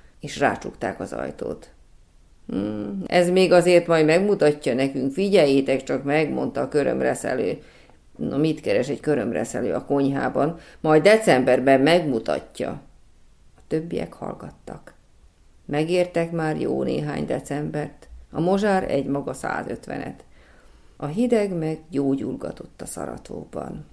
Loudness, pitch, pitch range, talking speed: -22 LUFS, 155 Hz, 135-175 Hz, 115 wpm